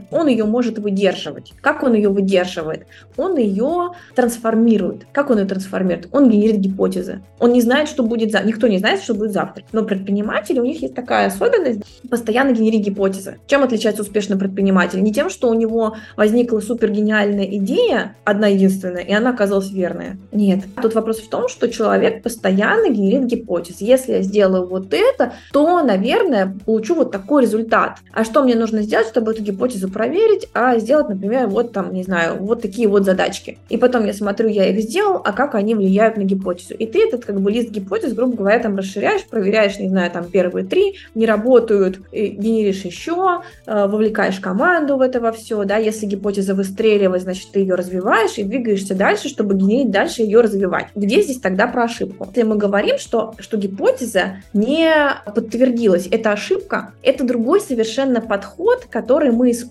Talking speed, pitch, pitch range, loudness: 180 wpm, 220 Hz, 200-245 Hz, -17 LUFS